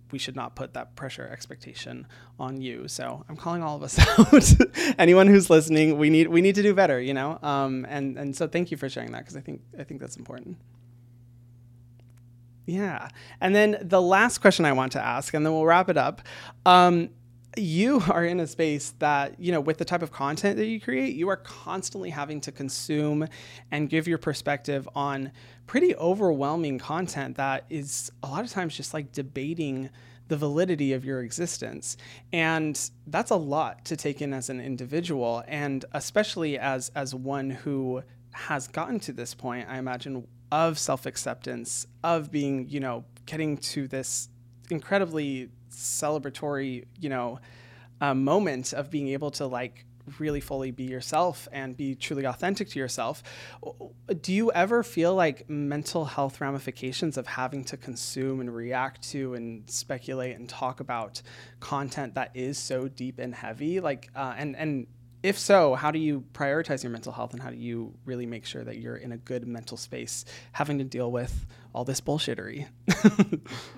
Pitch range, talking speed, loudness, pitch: 125-160 Hz, 180 wpm, -26 LUFS, 140 Hz